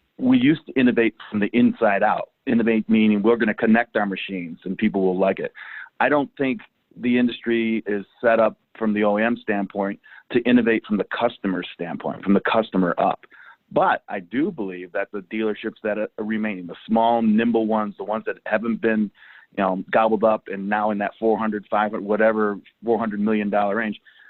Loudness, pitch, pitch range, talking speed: -22 LUFS, 110 Hz, 105-115 Hz, 195 wpm